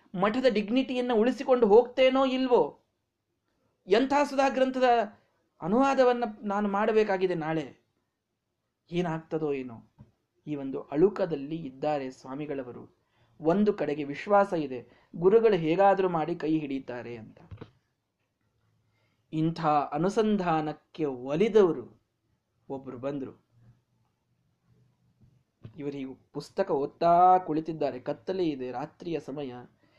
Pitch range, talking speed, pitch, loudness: 130-200 Hz, 85 wpm, 150 Hz, -27 LUFS